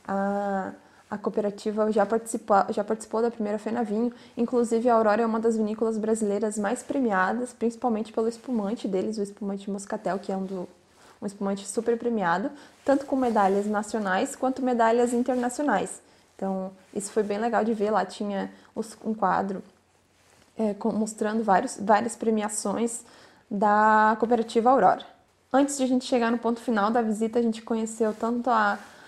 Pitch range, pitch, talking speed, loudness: 205-235 Hz, 220 Hz, 160 wpm, -26 LUFS